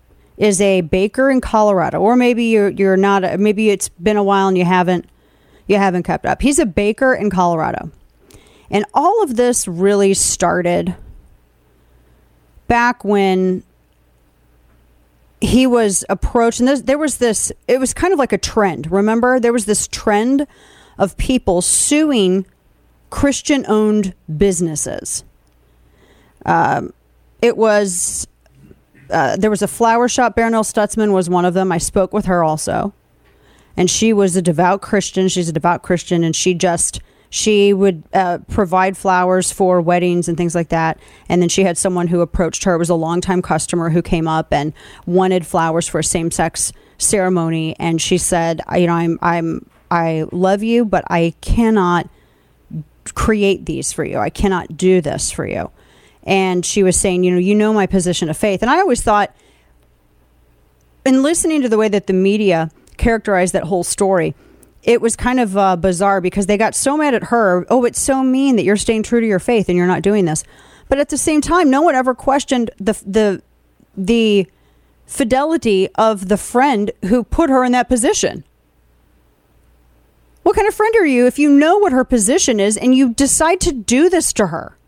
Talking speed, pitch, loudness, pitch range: 175 wpm, 195 Hz, -15 LUFS, 175-230 Hz